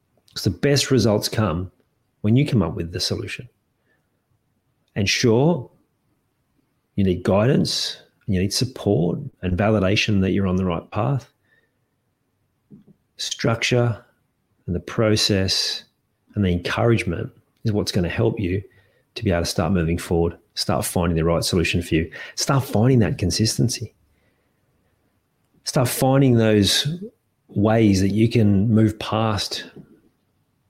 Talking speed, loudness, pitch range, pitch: 135 wpm, -21 LUFS, 95-120 Hz, 110 Hz